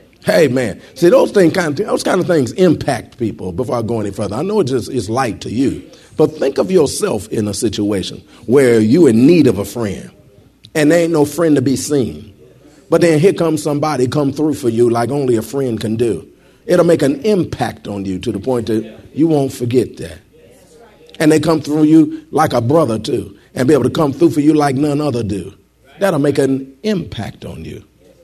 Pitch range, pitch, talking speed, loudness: 115-155 Hz, 140 Hz, 220 wpm, -15 LUFS